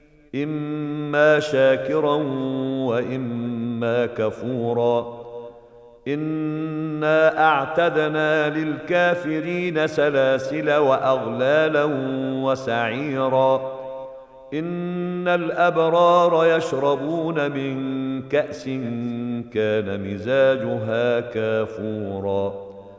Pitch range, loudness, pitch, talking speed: 120-155 Hz, -21 LUFS, 135 Hz, 45 wpm